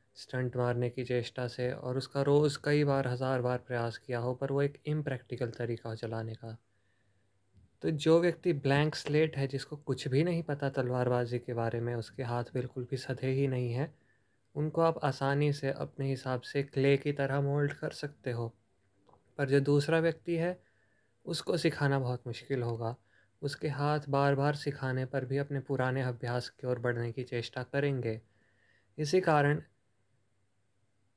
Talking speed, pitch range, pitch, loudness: 170 wpm, 120-145 Hz, 130 Hz, -33 LUFS